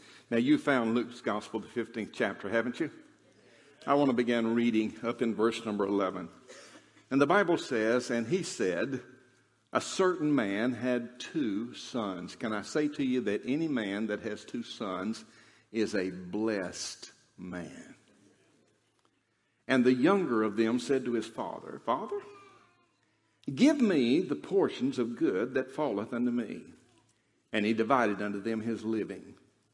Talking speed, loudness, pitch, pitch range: 155 wpm, -31 LUFS, 120 Hz, 110-135 Hz